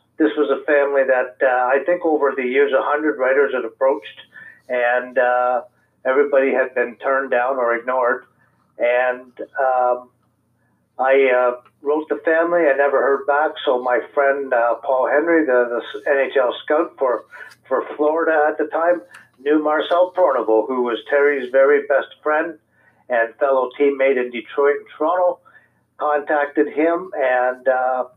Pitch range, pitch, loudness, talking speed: 125-150 Hz, 140 Hz, -18 LUFS, 155 wpm